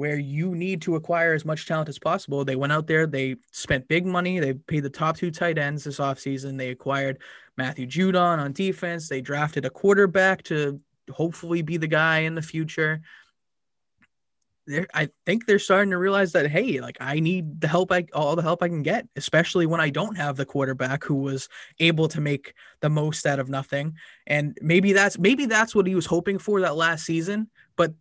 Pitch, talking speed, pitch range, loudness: 160 Hz, 210 wpm, 145-175 Hz, -24 LUFS